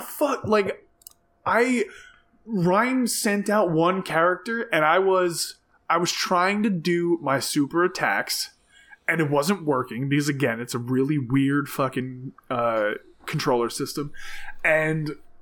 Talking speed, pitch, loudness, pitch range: 130 wpm, 175 Hz, -23 LUFS, 145-220 Hz